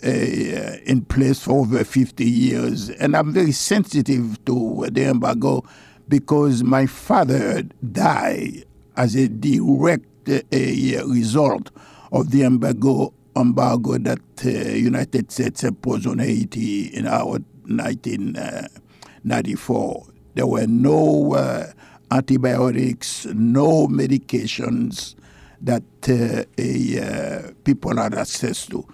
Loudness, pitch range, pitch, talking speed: -20 LUFS, 120-135 Hz, 130 Hz, 110 wpm